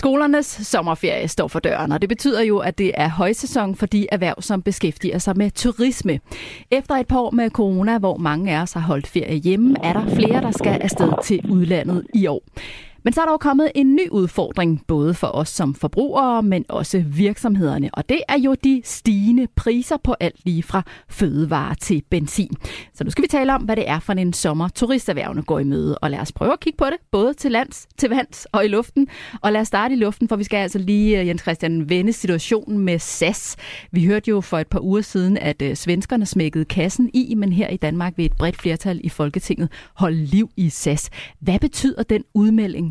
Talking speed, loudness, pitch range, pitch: 220 wpm, -20 LUFS, 170-235 Hz, 195 Hz